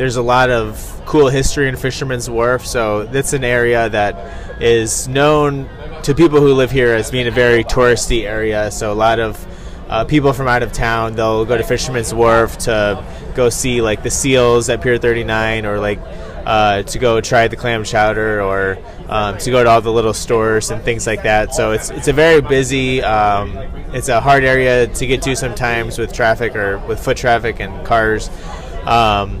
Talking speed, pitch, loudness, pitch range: 200 wpm, 115 Hz, -14 LUFS, 105-125 Hz